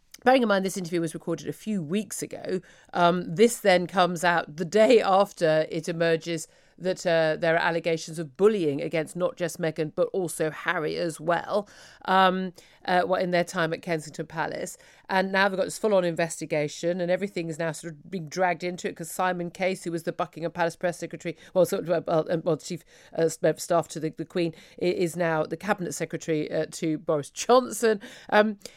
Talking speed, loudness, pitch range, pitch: 200 wpm, -26 LUFS, 165-185 Hz, 175 Hz